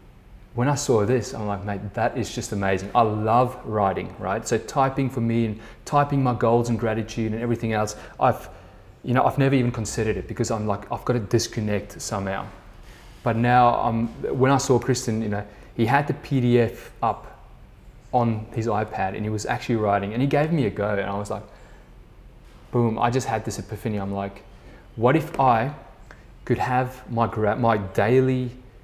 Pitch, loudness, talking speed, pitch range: 115 Hz, -23 LUFS, 190 wpm, 105-125 Hz